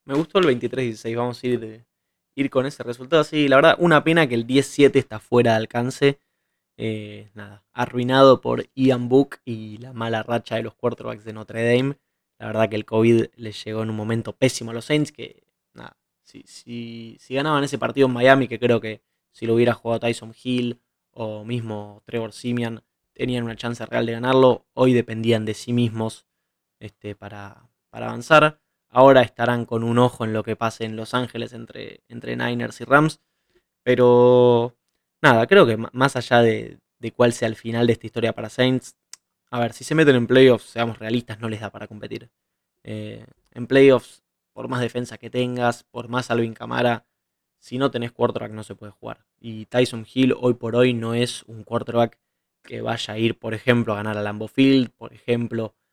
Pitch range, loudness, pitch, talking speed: 110-125 Hz, -20 LUFS, 120 Hz, 195 wpm